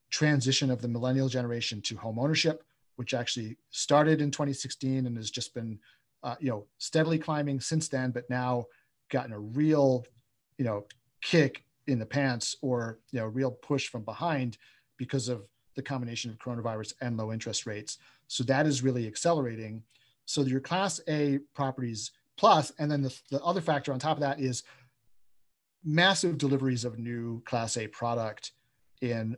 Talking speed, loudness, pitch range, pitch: 165 wpm, -30 LUFS, 115-140 Hz, 130 Hz